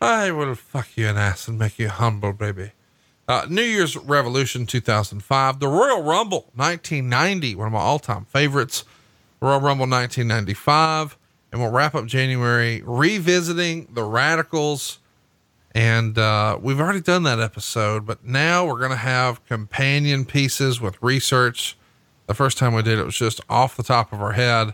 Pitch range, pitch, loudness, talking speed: 110-145 Hz, 125 Hz, -20 LUFS, 165 wpm